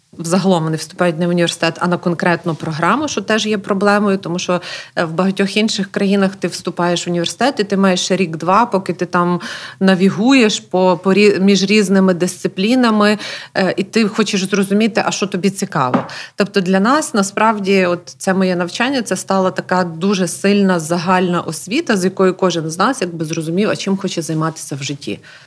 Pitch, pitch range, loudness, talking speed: 190 Hz, 175-205 Hz, -16 LUFS, 175 wpm